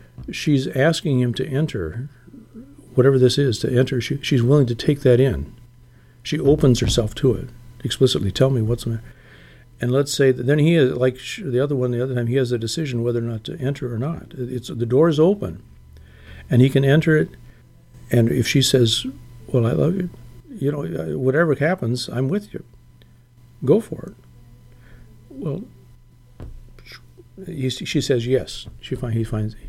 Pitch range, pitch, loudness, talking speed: 120-135 Hz, 125 Hz, -20 LUFS, 180 wpm